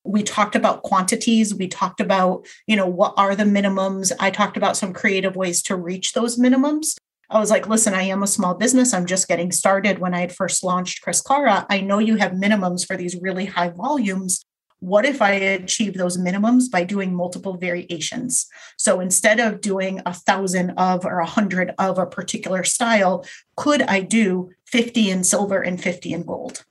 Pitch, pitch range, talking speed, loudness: 195 Hz, 185-215 Hz, 195 wpm, -19 LUFS